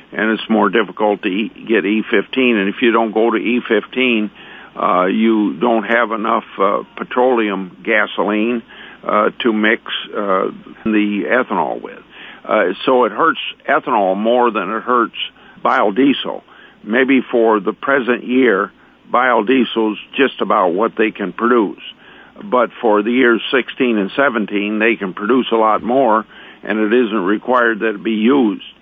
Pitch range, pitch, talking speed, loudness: 110-120 Hz, 115 Hz, 150 wpm, -16 LUFS